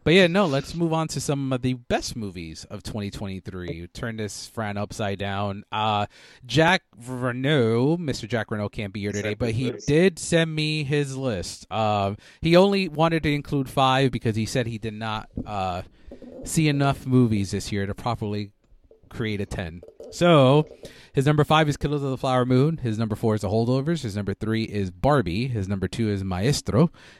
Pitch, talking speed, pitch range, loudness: 120 Hz, 195 wpm, 105-145 Hz, -24 LUFS